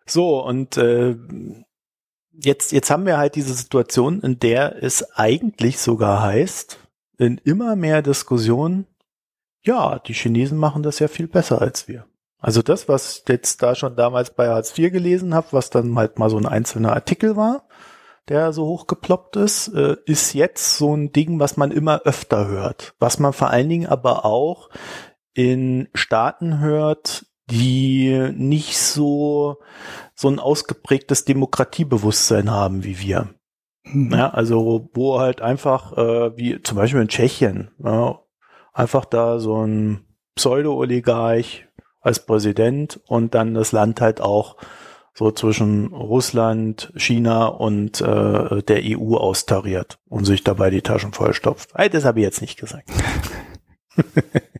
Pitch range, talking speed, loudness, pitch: 115-150 Hz, 145 wpm, -19 LUFS, 125 Hz